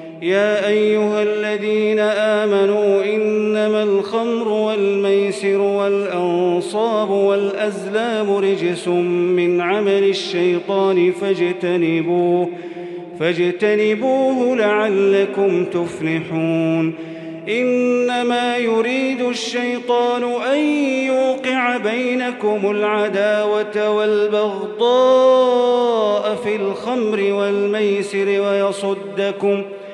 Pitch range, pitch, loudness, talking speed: 195-220 Hz, 205 Hz, -17 LUFS, 60 wpm